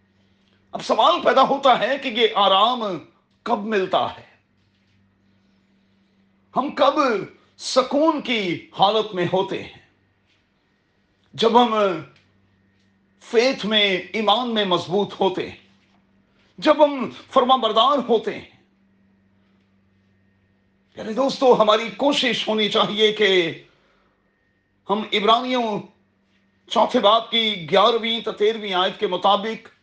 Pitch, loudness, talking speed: 195 Hz, -19 LUFS, 105 wpm